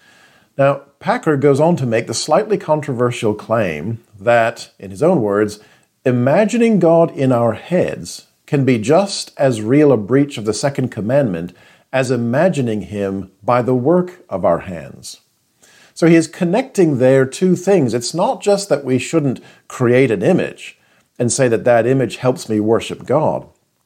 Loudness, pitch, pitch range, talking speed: -16 LUFS, 130 Hz, 115-155 Hz, 165 wpm